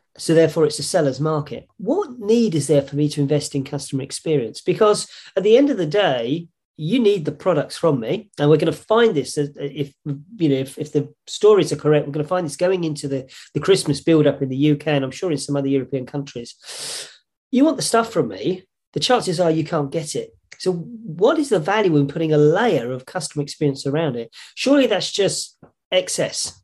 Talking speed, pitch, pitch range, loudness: 220 wpm, 155 Hz, 145-185 Hz, -20 LUFS